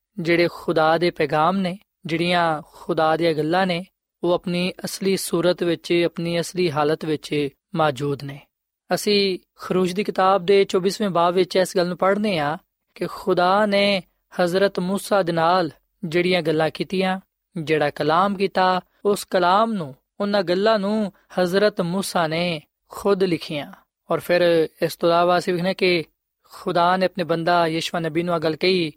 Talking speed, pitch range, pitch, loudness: 135 wpm, 165-190 Hz, 180 Hz, -21 LUFS